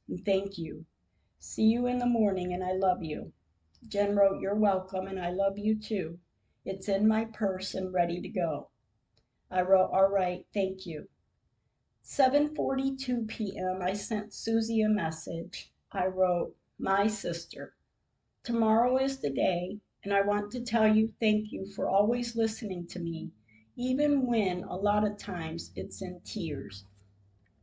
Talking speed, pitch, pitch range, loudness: 155 wpm, 195 Hz, 175-215 Hz, -30 LUFS